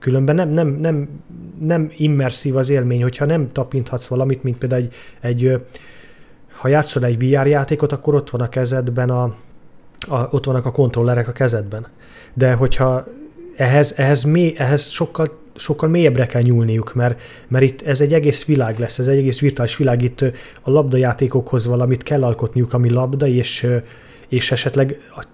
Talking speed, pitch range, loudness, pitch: 165 wpm, 125-145 Hz, -17 LUFS, 130 Hz